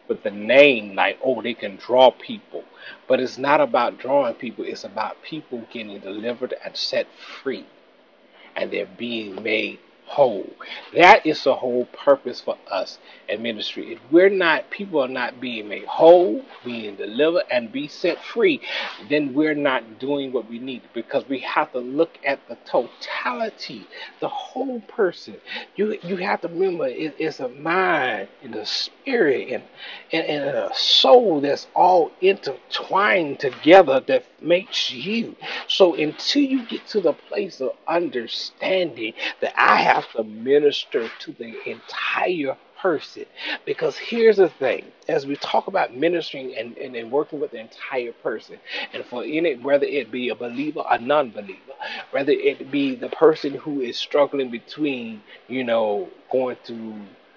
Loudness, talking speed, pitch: -21 LUFS, 165 wpm, 155 Hz